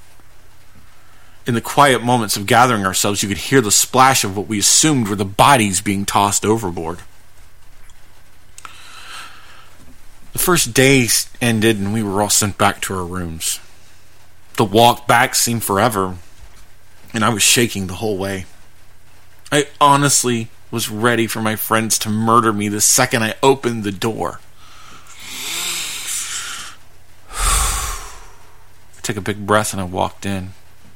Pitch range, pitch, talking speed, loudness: 95-115 Hz, 105 Hz, 140 wpm, -16 LUFS